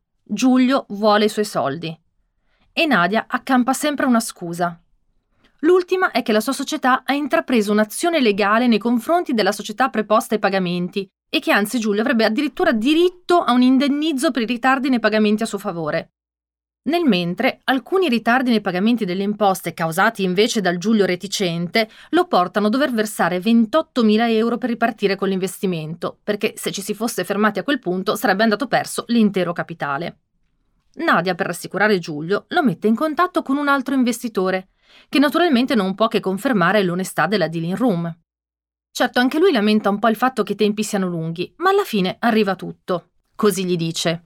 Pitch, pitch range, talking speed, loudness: 215 Hz, 190-255 Hz, 170 wpm, -19 LUFS